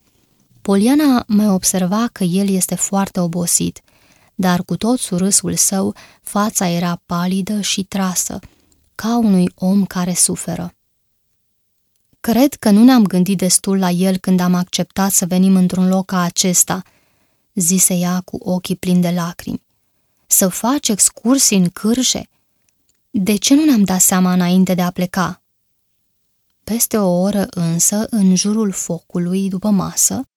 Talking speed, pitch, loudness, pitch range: 140 wpm, 185 Hz, -15 LUFS, 175-205 Hz